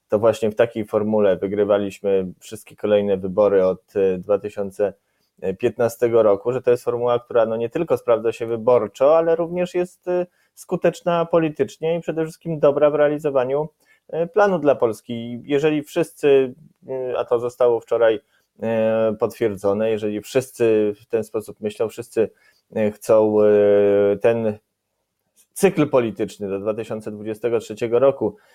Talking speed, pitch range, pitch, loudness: 120 wpm, 105-150 Hz, 115 Hz, -20 LUFS